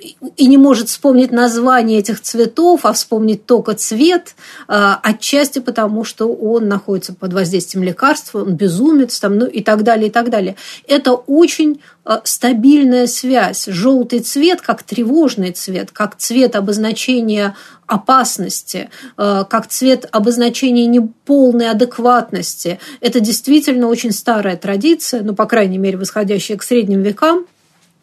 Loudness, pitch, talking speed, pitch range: -13 LUFS, 230 Hz, 130 wpm, 205-260 Hz